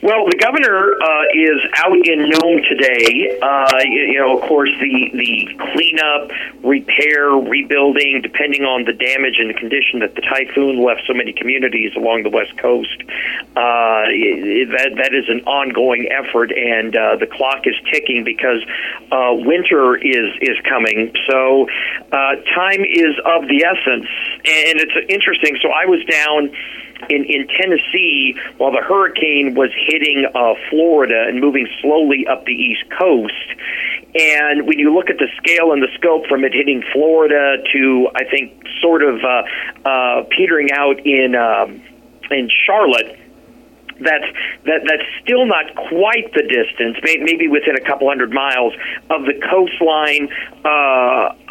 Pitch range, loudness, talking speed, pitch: 135-165 Hz, -14 LUFS, 155 wpm, 150 Hz